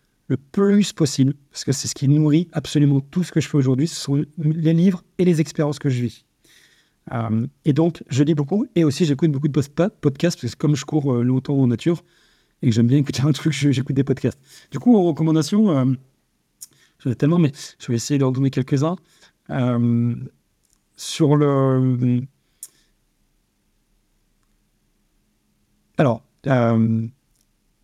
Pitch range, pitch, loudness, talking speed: 130-160 Hz, 145 Hz, -20 LUFS, 170 wpm